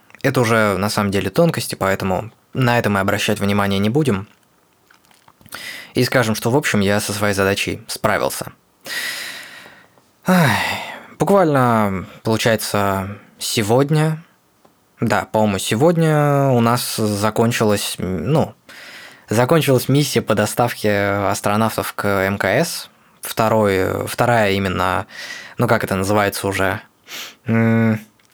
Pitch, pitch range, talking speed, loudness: 110 Hz, 100-125 Hz, 105 wpm, -18 LUFS